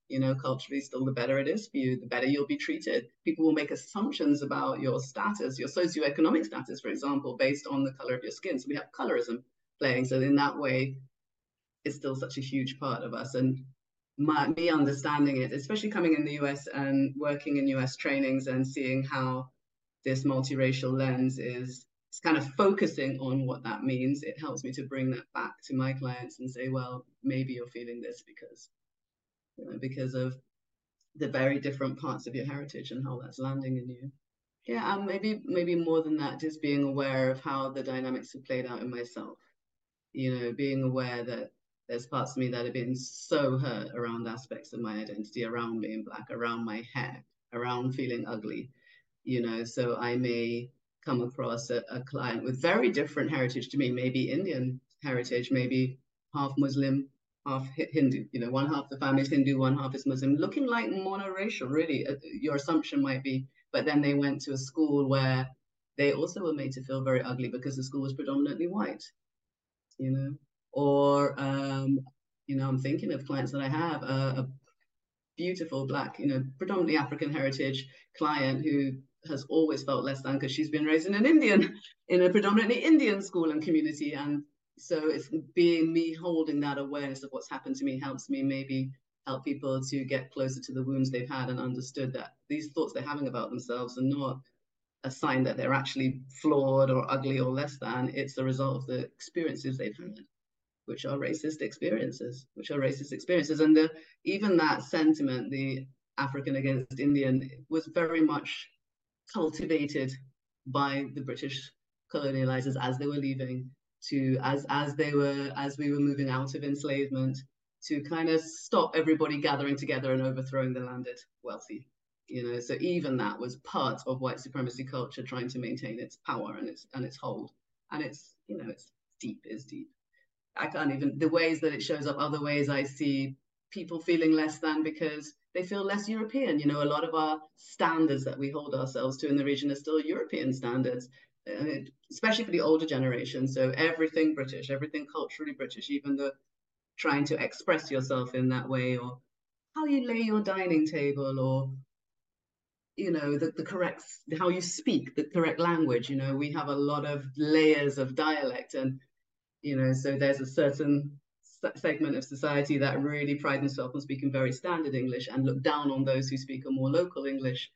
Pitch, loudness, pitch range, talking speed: 135 Hz, -31 LUFS, 130-150 Hz, 190 wpm